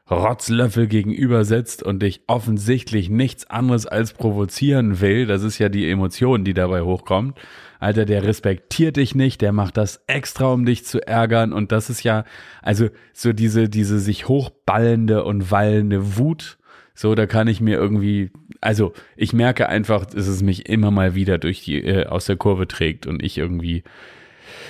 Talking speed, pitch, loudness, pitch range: 170 wpm, 110 Hz, -19 LUFS, 100-120 Hz